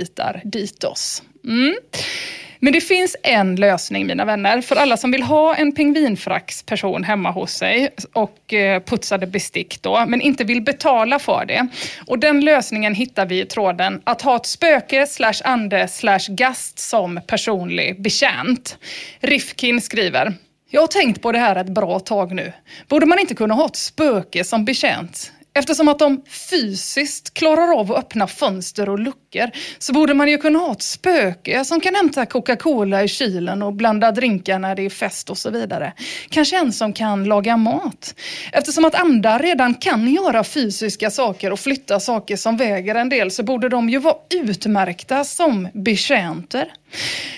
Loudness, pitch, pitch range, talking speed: -18 LUFS, 240 Hz, 205-290 Hz, 165 wpm